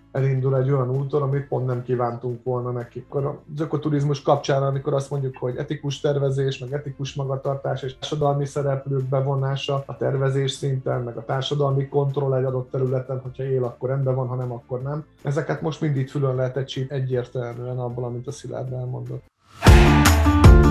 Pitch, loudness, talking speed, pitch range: 135 Hz, -23 LUFS, 165 wpm, 125-140 Hz